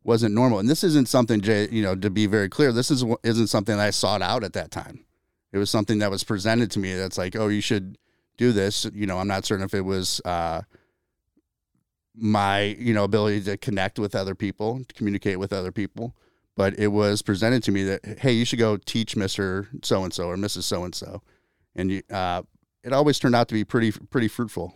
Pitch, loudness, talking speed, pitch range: 105 Hz, -24 LUFS, 215 wpm, 95-115 Hz